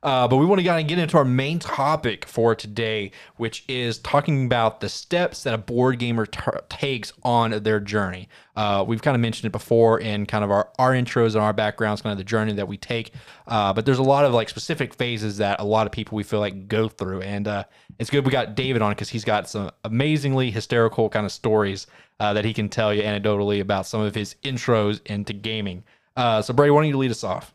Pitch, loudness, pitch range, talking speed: 110 Hz, -22 LUFS, 105-125 Hz, 240 wpm